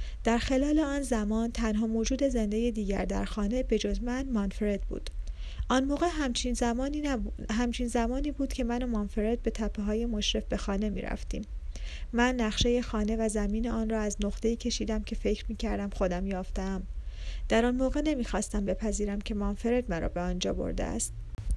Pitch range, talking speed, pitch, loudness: 205-245 Hz, 180 wpm, 225 Hz, -31 LUFS